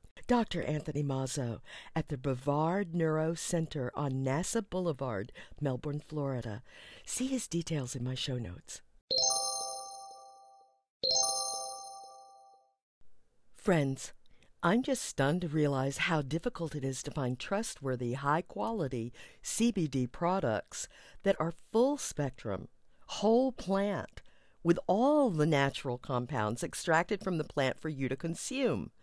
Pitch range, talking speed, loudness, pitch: 130-170 Hz, 115 wpm, -33 LUFS, 145 Hz